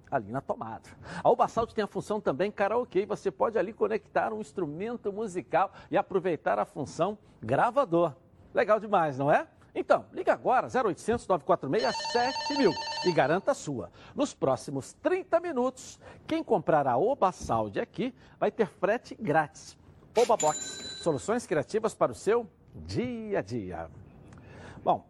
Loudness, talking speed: -29 LUFS, 150 wpm